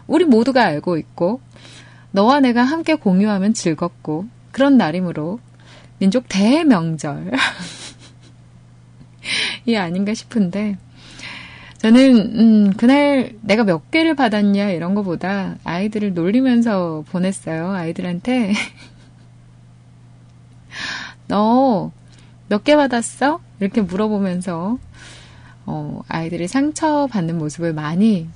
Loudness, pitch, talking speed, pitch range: -17 LUFS, 195 Hz, 220 characters per minute, 165-235 Hz